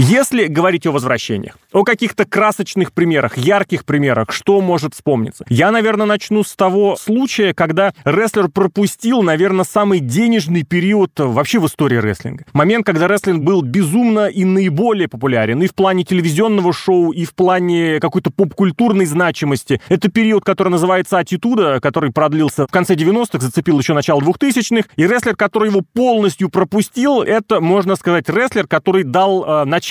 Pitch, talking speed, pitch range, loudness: 185 Hz, 155 wpm, 160-205 Hz, -14 LUFS